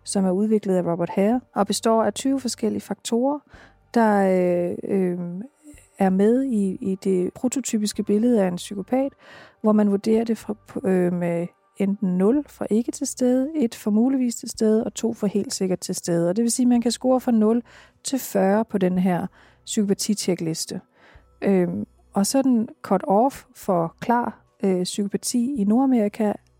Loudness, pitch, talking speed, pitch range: -22 LUFS, 210 Hz, 175 wpm, 190-240 Hz